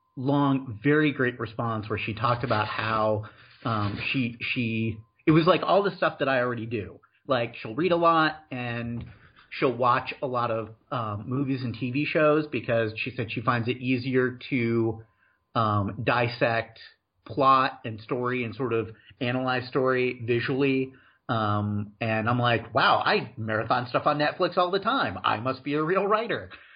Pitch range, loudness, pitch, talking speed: 115-140 Hz, -26 LUFS, 125 Hz, 170 wpm